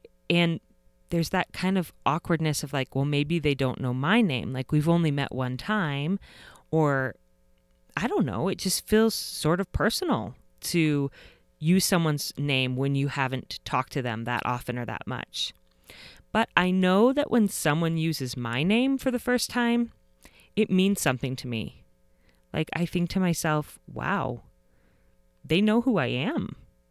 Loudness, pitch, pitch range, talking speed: -26 LUFS, 150 Hz, 130-185 Hz, 165 wpm